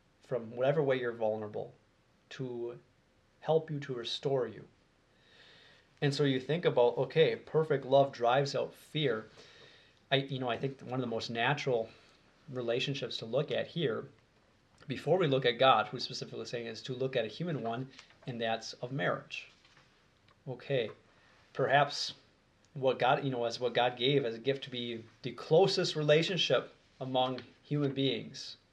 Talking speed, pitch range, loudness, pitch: 165 wpm, 120-140 Hz, -32 LUFS, 130 Hz